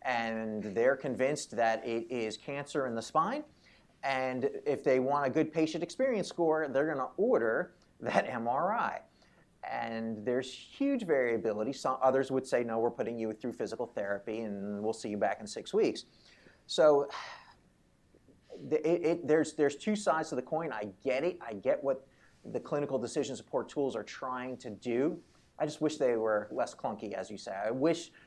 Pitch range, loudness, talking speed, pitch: 115-155 Hz, -33 LUFS, 180 wpm, 130 Hz